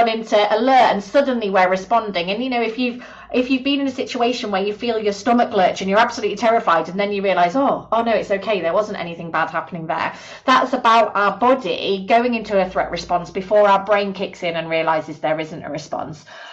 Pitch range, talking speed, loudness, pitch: 185-230 Hz, 225 wpm, -19 LUFS, 205 Hz